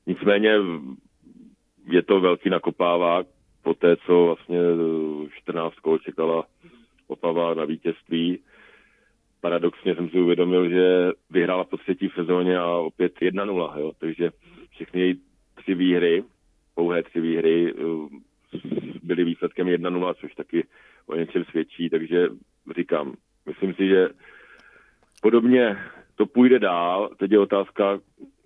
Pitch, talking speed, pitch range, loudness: 85 Hz, 115 wpm, 85-90 Hz, -23 LUFS